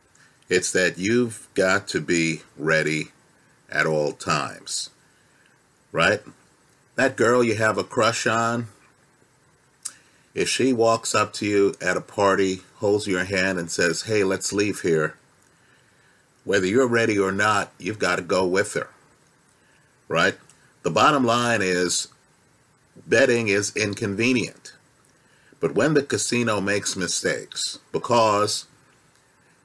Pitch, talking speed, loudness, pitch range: 100 Hz, 125 wpm, -22 LUFS, 95-115 Hz